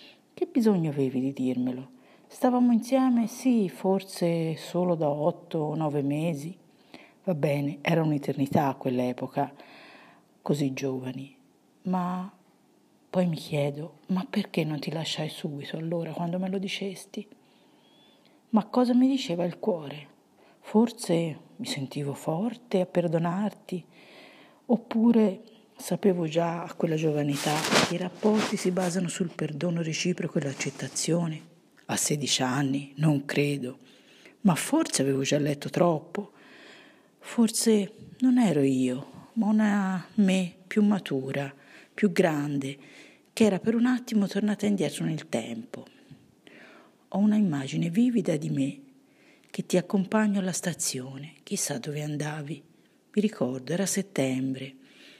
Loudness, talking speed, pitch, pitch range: -27 LUFS, 125 wpm, 175 Hz, 145-210 Hz